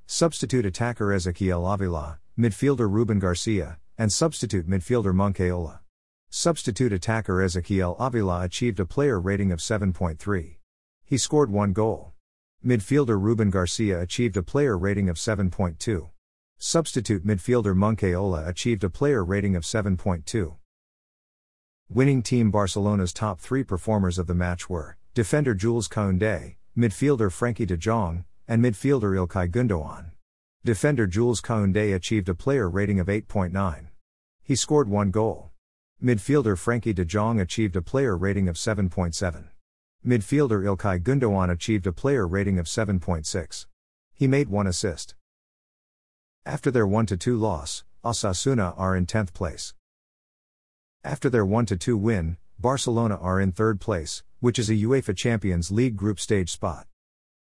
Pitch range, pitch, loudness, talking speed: 90-115 Hz, 100 Hz, -25 LUFS, 130 wpm